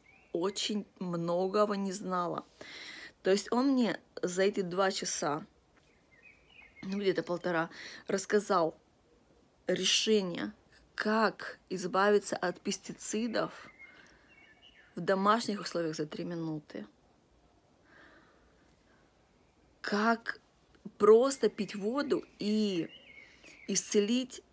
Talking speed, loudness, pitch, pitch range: 80 wpm, -31 LUFS, 200 Hz, 180-215 Hz